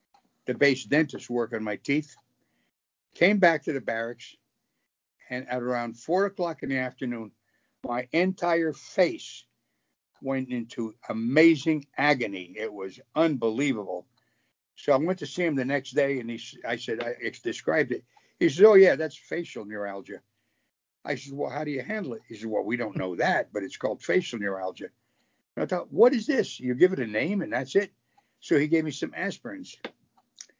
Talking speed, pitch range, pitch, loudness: 180 wpm, 120-160 Hz, 135 Hz, -27 LUFS